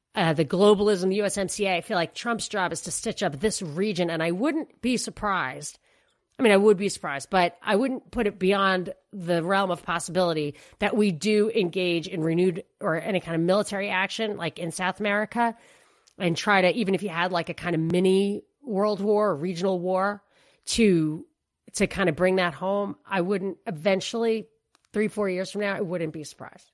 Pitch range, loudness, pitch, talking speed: 175-210 Hz, -25 LUFS, 195 Hz, 200 wpm